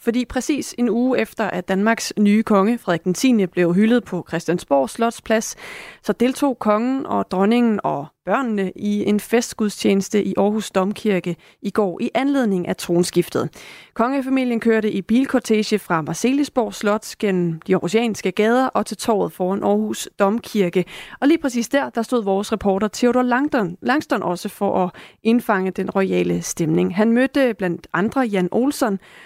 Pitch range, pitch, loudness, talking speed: 190-240 Hz, 210 Hz, -20 LUFS, 155 wpm